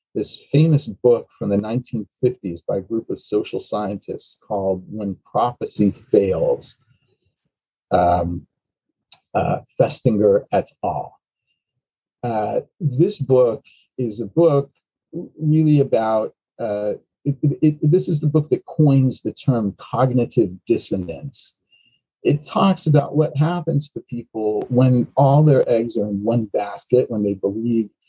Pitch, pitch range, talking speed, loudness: 130 Hz, 110-150 Hz, 130 wpm, -20 LUFS